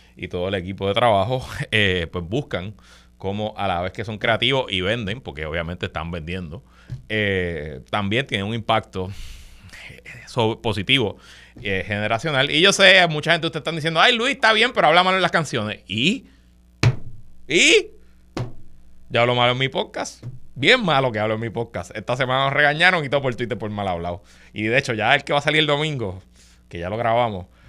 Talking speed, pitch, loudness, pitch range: 195 wpm, 115 Hz, -20 LUFS, 95-145 Hz